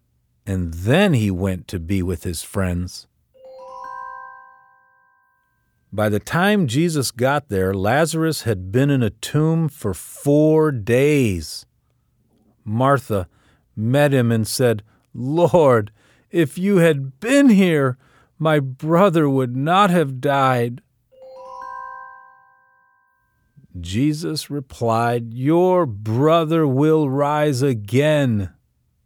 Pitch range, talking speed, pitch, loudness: 95-155 Hz, 100 wpm, 125 Hz, -19 LUFS